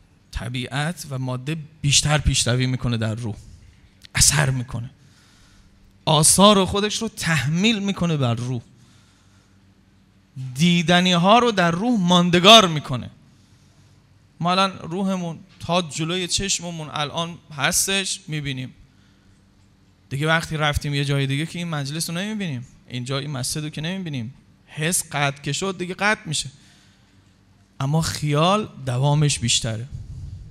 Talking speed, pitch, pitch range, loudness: 120 wpm, 145 Hz, 115-170 Hz, -20 LUFS